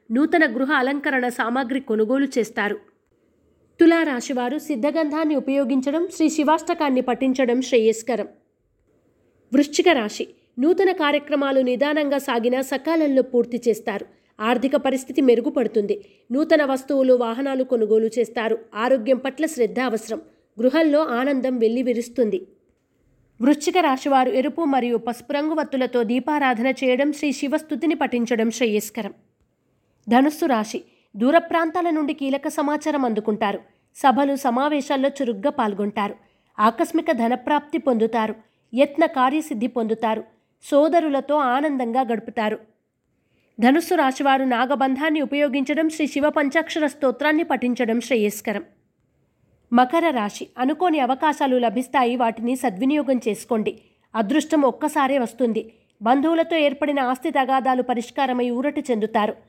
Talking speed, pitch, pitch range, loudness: 100 wpm, 265 Hz, 240-295 Hz, -21 LUFS